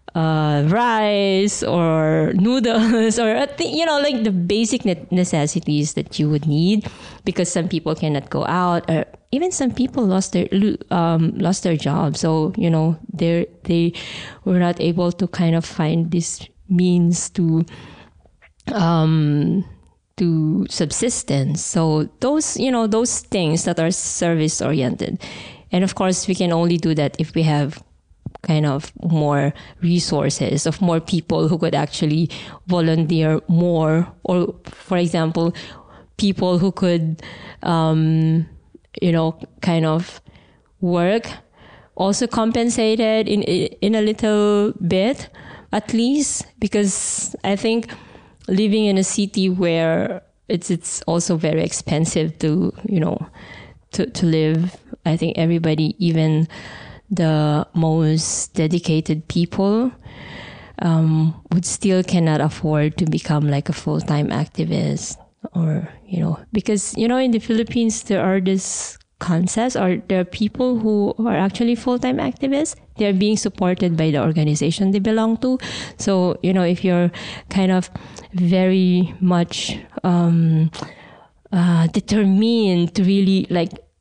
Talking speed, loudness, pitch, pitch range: 135 wpm, -19 LUFS, 175 Hz, 160-205 Hz